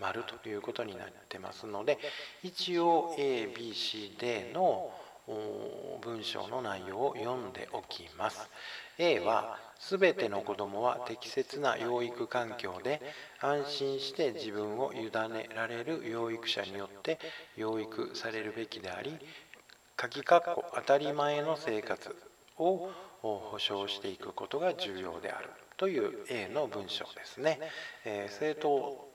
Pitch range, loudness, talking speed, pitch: 110-165 Hz, -35 LUFS, 245 characters per minute, 135 Hz